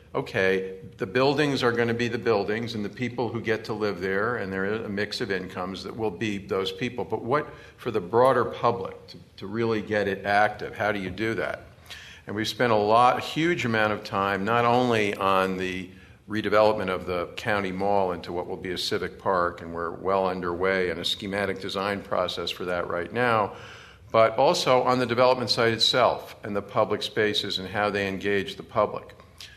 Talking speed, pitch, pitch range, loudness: 205 wpm, 105 Hz, 95-115 Hz, -25 LUFS